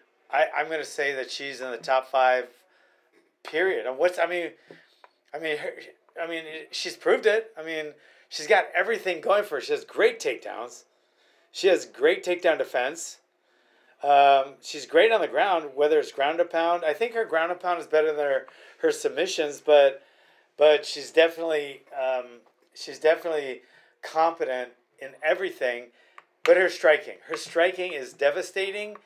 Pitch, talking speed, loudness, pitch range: 165 Hz, 165 wpm, -25 LUFS, 140-215 Hz